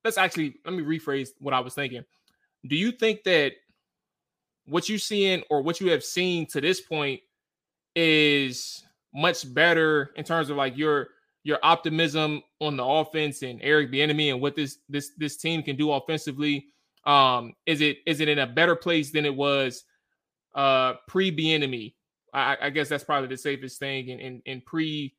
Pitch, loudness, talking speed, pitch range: 150 Hz, -25 LUFS, 180 wpm, 140-165 Hz